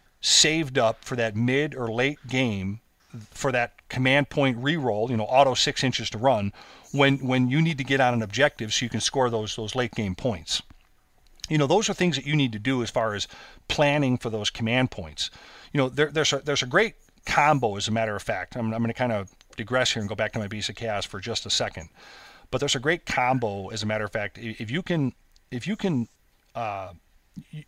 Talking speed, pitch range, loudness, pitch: 230 wpm, 110-140 Hz, -25 LUFS, 125 Hz